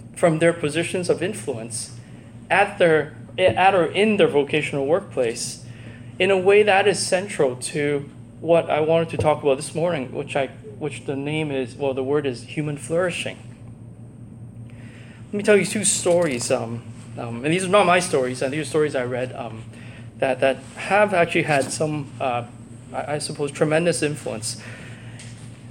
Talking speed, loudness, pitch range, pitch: 170 wpm, -21 LUFS, 120-165 Hz, 135 Hz